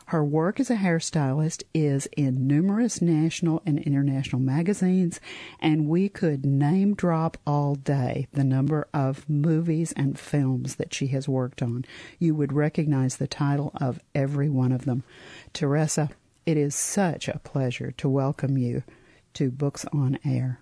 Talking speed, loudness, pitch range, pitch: 155 wpm, -25 LUFS, 135-160 Hz, 145 Hz